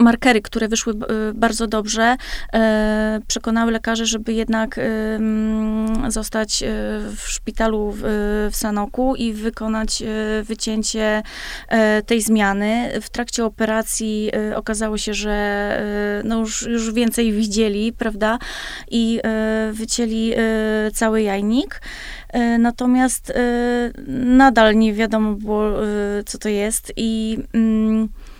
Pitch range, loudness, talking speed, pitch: 215-230 Hz, -19 LUFS, 95 wpm, 220 Hz